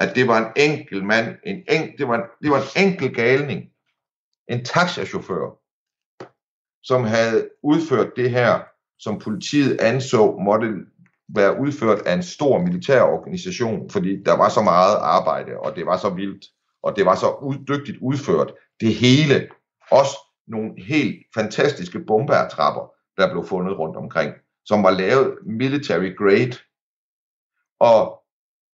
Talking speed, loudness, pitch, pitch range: 145 wpm, -20 LUFS, 130 Hz, 110-150 Hz